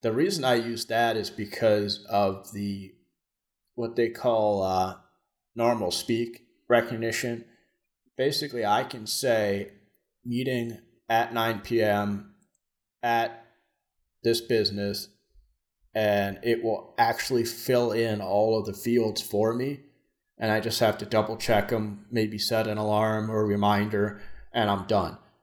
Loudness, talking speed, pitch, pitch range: -27 LUFS, 135 wpm, 110 Hz, 105-115 Hz